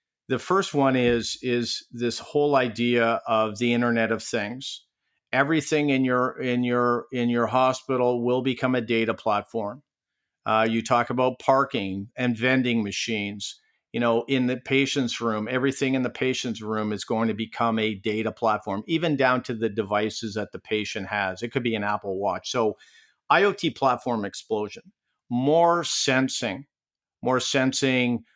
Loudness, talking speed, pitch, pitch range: -24 LUFS, 160 wpm, 120 Hz, 110-130 Hz